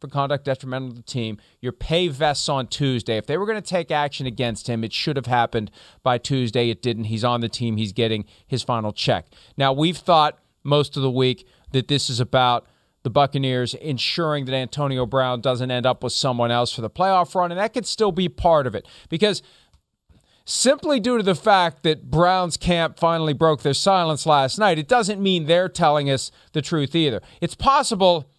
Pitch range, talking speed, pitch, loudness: 125-170 Hz, 205 wpm, 140 Hz, -21 LUFS